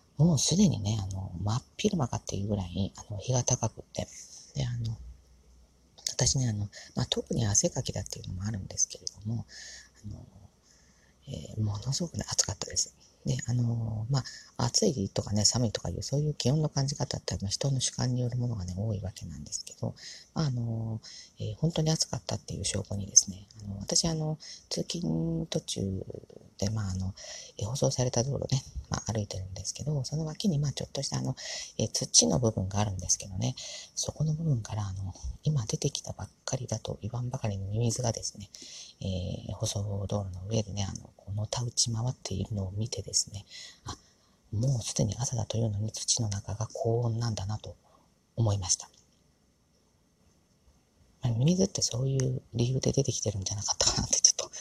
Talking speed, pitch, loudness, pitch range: 365 characters per minute, 110 Hz, -30 LUFS, 100-130 Hz